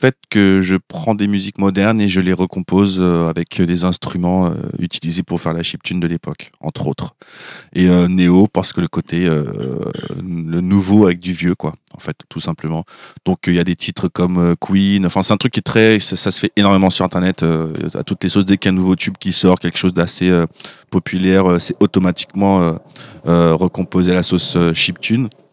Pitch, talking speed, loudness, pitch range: 90 Hz, 205 wpm, -15 LUFS, 85-95 Hz